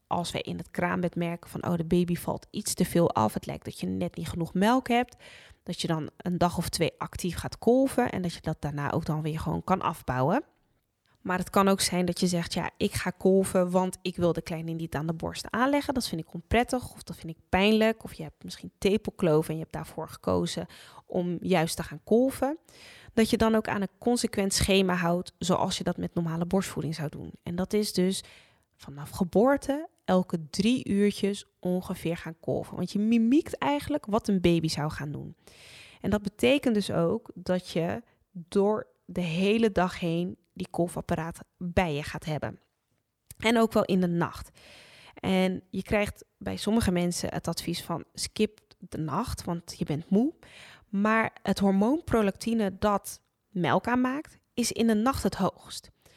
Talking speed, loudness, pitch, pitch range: 195 wpm, -28 LUFS, 185 Hz, 170-215 Hz